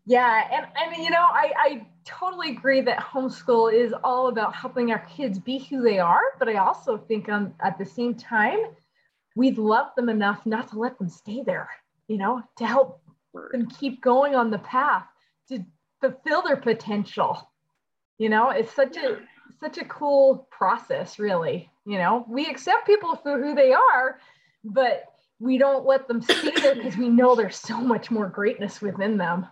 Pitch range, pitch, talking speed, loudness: 220-275 Hz, 250 Hz, 185 wpm, -23 LUFS